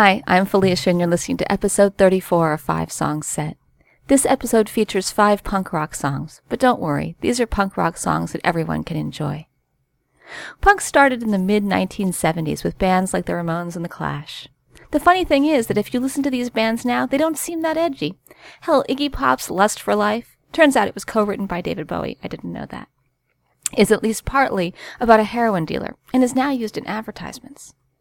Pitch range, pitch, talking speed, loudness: 175-250 Hz, 205 Hz, 200 wpm, -19 LUFS